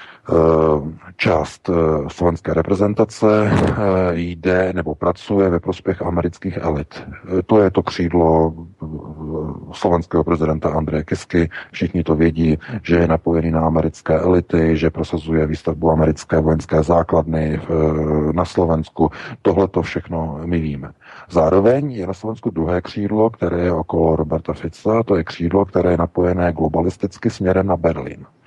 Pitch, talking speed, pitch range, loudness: 85 Hz, 130 wpm, 80-95 Hz, -18 LUFS